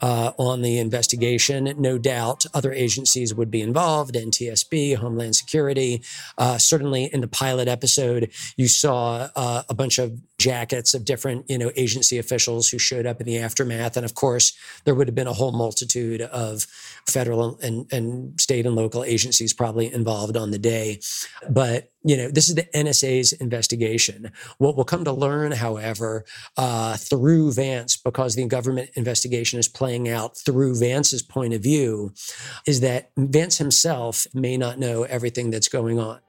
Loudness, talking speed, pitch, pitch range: -21 LUFS, 170 wpm, 125 Hz, 115-135 Hz